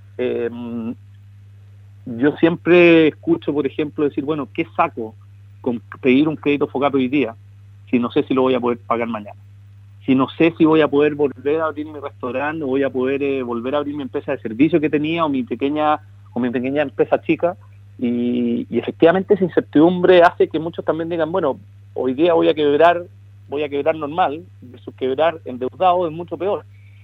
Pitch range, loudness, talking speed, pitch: 120-160 Hz, -18 LUFS, 190 wpm, 140 Hz